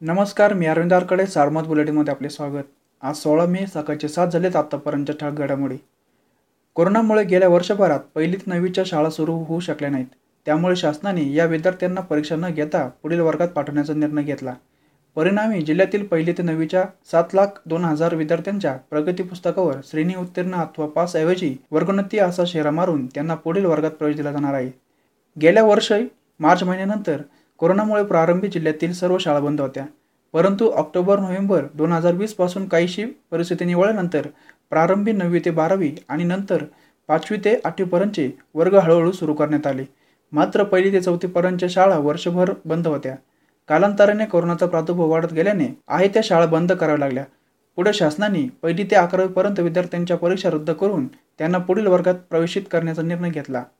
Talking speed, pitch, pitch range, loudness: 150 wpm, 170 Hz, 150-185 Hz, -20 LUFS